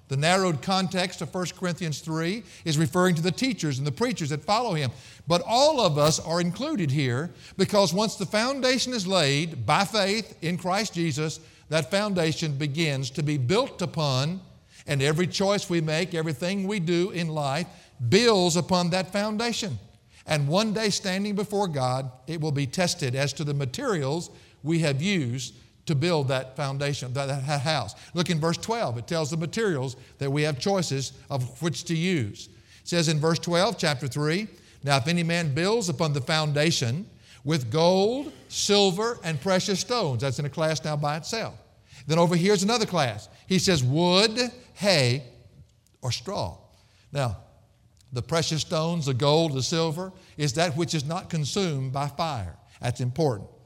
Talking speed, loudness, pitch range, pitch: 170 wpm, -26 LUFS, 140-185 Hz, 160 Hz